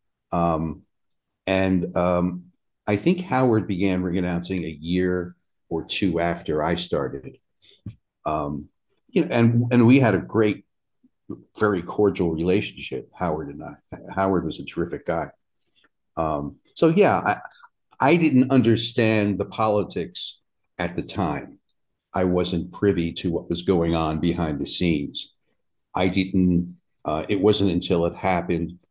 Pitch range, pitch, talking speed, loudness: 85-105 Hz, 90 Hz, 140 wpm, -23 LUFS